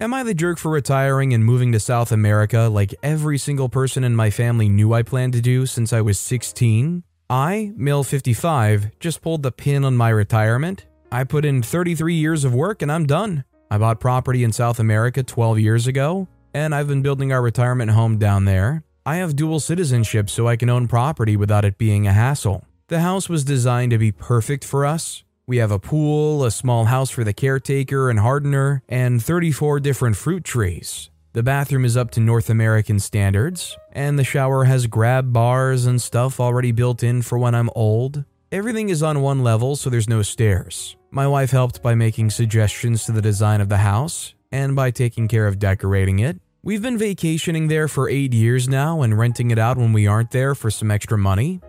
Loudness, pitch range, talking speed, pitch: -19 LUFS, 110-140 Hz, 205 wpm, 125 Hz